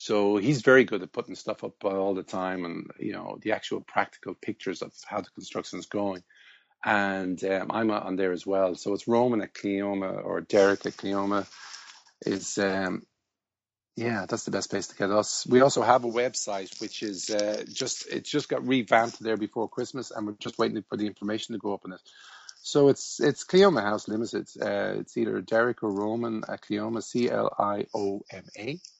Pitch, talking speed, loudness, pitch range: 105 Hz, 195 wpm, -28 LUFS, 100-120 Hz